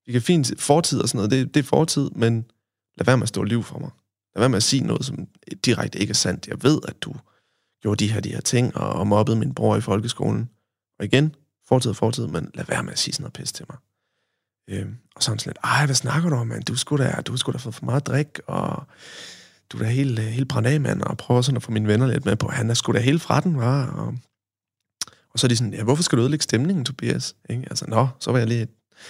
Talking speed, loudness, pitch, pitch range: 270 wpm, -22 LUFS, 125 Hz, 110-140 Hz